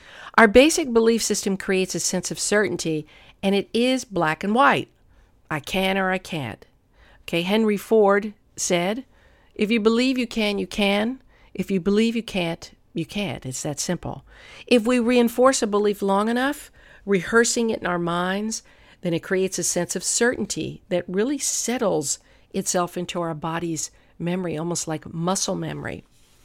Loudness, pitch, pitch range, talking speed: -22 LUFS, 195 Hz, 175-225 Hz, 165 wpm